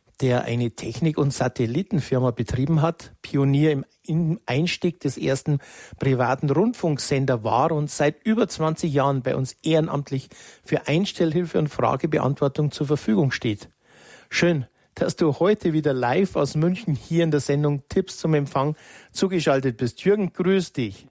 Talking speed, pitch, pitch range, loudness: 140 wpm, 150 Hz, 130-170 Hz, -23 LUFS